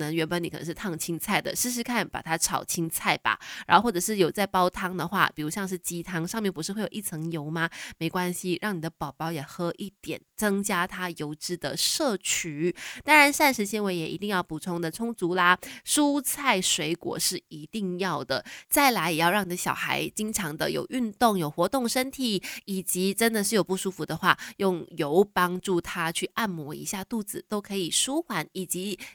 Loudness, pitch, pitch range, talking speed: -27 LUFS, 180 Hz, 165-210 Hz, 290 characters per minute